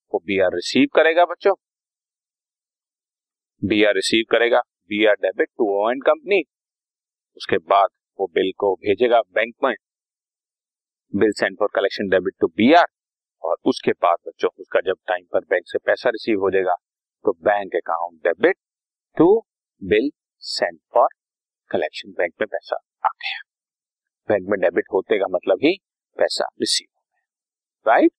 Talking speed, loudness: 145 wpm, -20 LUFS